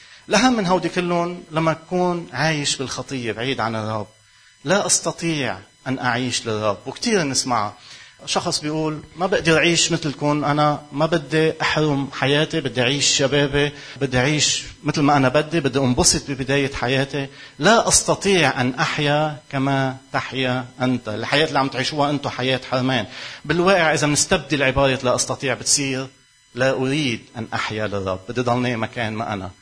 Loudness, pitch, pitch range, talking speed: -20 LUFS, 140 Hz, 125-155 Hz, 150 wpm